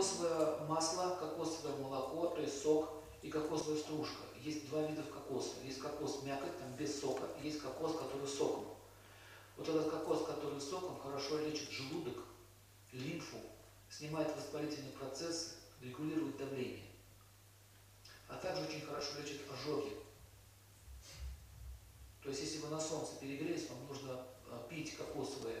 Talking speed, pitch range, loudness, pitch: 130 wpm, 115-155 Hz, -42 LUFS, 145 Hz